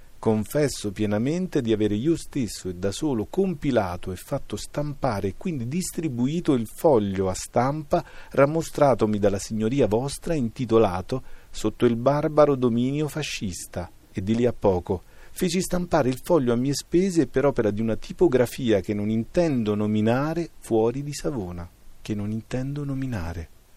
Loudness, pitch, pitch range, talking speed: -24 LUFS, 120 Hz, 105-145 Hz, 145 wpm